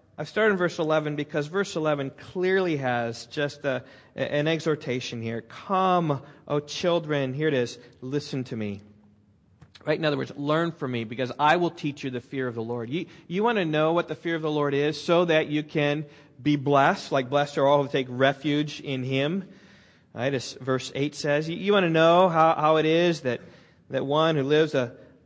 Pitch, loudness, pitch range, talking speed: 145 Hz, -25 LUFS, 130-160 Hz, 210 wpm